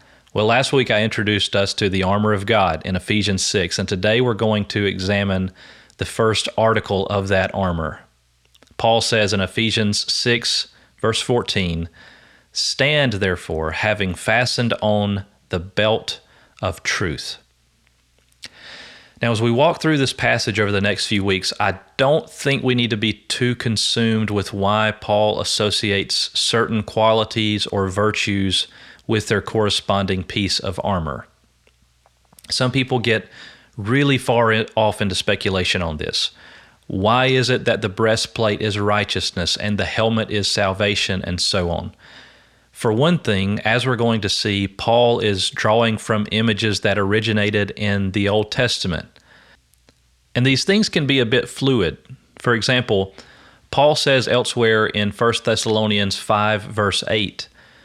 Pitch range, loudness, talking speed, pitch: 100-115 Hz, -19 LUFS, 145 wpm, 105 Hz